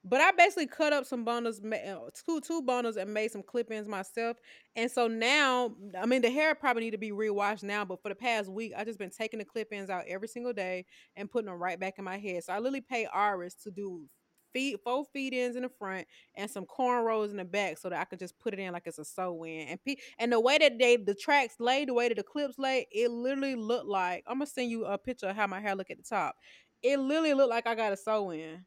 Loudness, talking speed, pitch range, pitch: -31 LUFS, 255 wpm, 195-255 Hz, 225 Hz